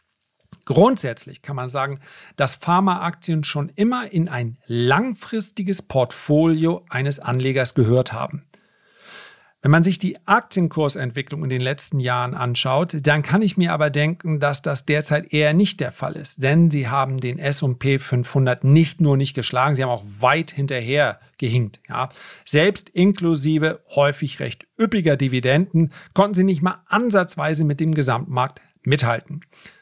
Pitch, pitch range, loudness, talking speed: 150 Hz, 135-170 Hz, -20 LUFS, 145 wpm